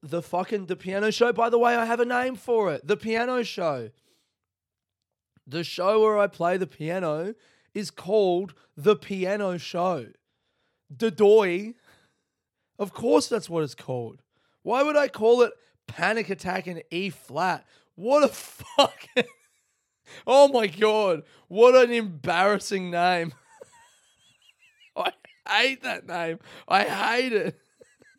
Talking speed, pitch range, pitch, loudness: 130 wpm, 170-230 Hz, 195 Hz, -24 LUFS